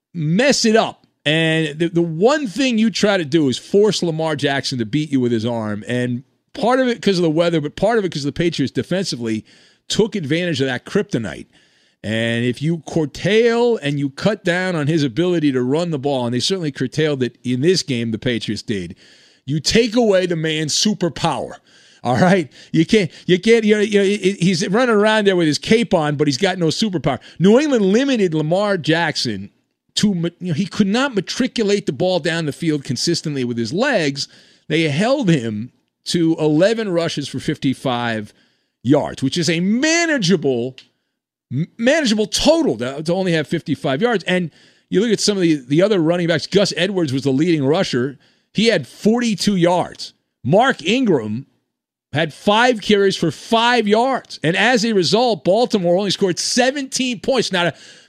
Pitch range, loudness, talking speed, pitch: 145-205 Hz, -18 LUFS, 185 wpm, 170 Hz